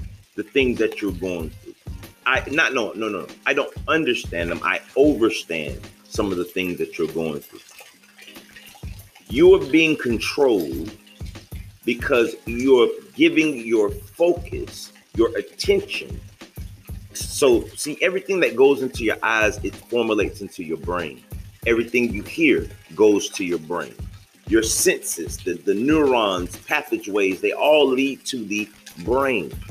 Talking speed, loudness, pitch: 140 wpm, -21 LUFS, 115 Hz